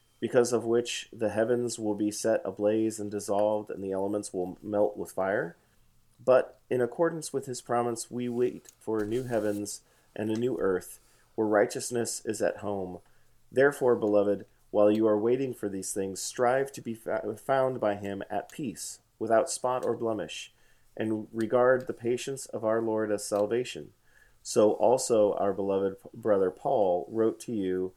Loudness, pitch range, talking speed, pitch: -29 LUFS, 105-120 Hz, 165 wpm, 110 Hz